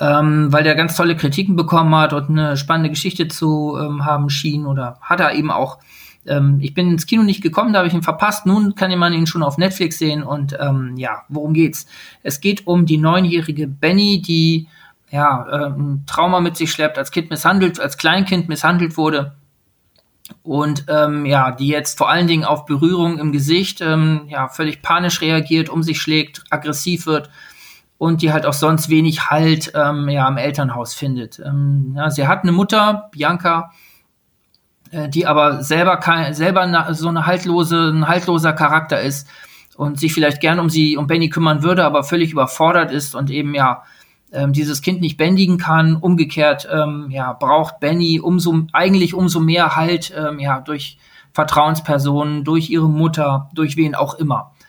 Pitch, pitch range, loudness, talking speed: 155 Hz, 145-170 Hz, -16 LUFS, 180 wpm